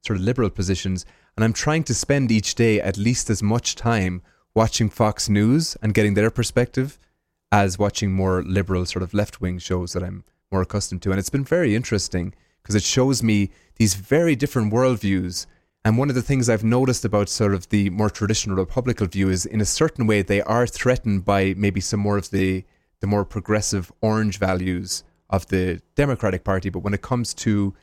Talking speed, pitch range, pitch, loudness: 200 wpm, 95-115 Hz, 105 Hz, -22 LUFS